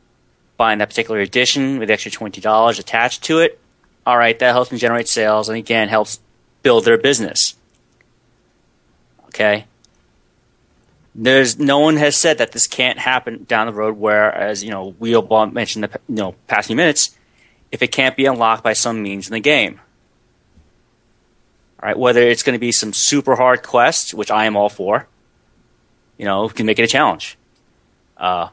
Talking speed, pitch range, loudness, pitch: 180 wpm, 110-125 Hz, -15 LUFS, 115 Hz